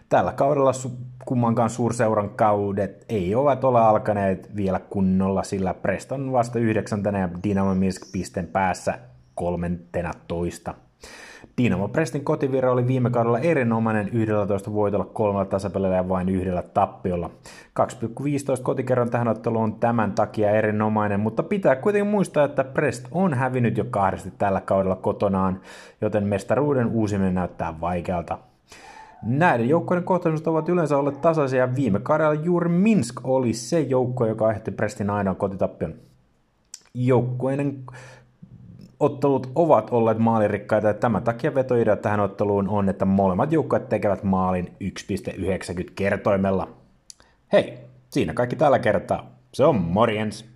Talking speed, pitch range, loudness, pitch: 125 wpm, 100-130 Hz, -23 LUFS, 110 Hz